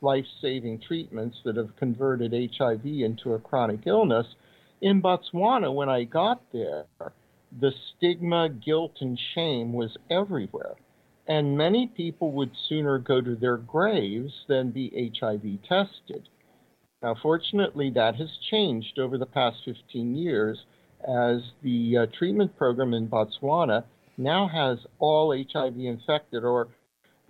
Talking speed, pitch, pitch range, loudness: 130 wpm, 130 Hz, 120-155 Hz, -27 LUFS